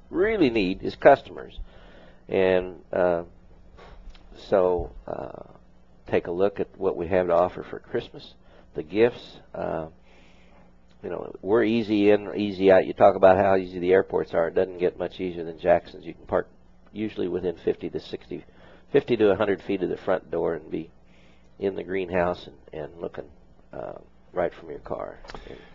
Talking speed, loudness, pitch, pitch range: 175 wpm, -24 LUFS, 90 Hz, 60-95 Hz